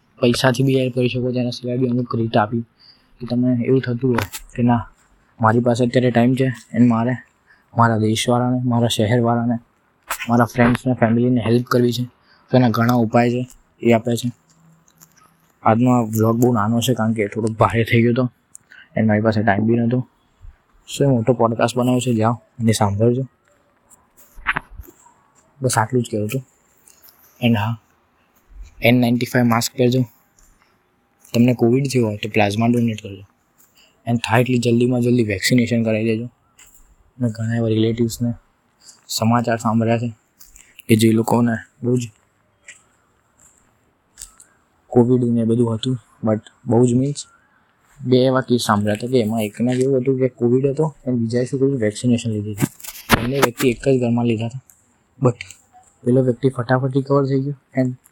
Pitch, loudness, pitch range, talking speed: 120 Hz, -18 LUFS, 115-125 Hz, 155 wpm